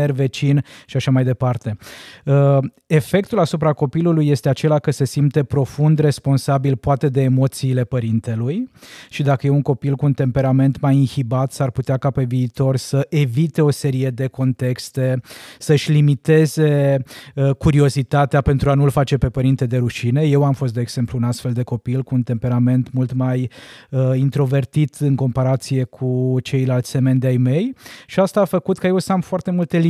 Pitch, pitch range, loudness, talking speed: 135 Hz, 130-145 Hz, -18 LUFS, 170 wpm